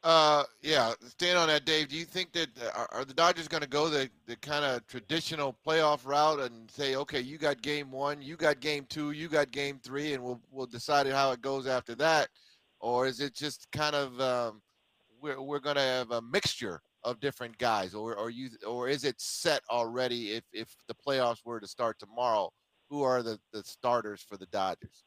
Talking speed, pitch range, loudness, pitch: 215 wpm, 120-150 Hz, -31 LUFS, 140 Hz